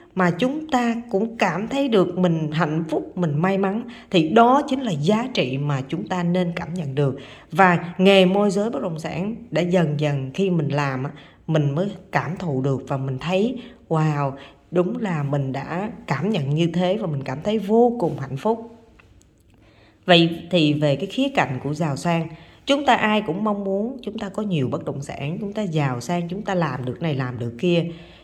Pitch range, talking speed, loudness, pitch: 145-200 Hz, 210 wpm, -22 LUFS, 175 Hz